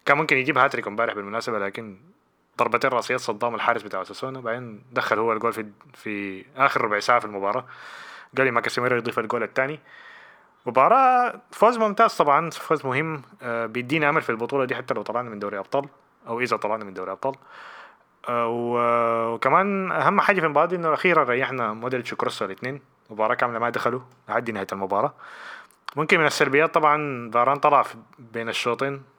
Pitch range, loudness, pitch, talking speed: 115-145 Hz, -23 LUFS, 125 Hz, 170 wpm